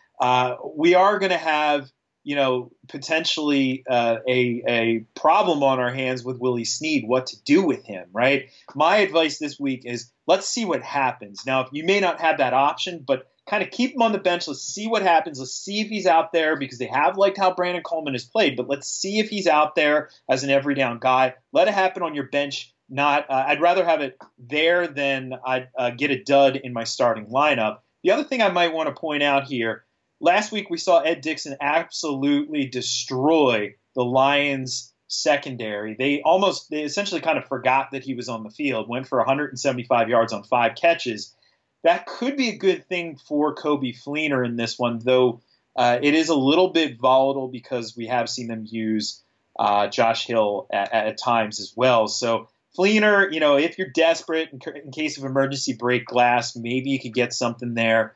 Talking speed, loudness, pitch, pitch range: 205 wpm, -22 LUFS, 140 Hz, 125-160 Hz